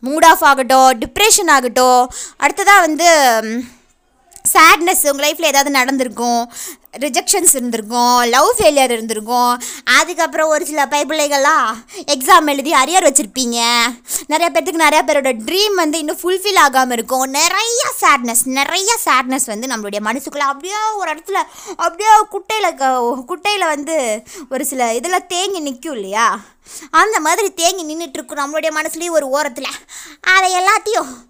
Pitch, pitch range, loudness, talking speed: 300 Hz, 260-350 Hz, -13 LUFS, 125 wpm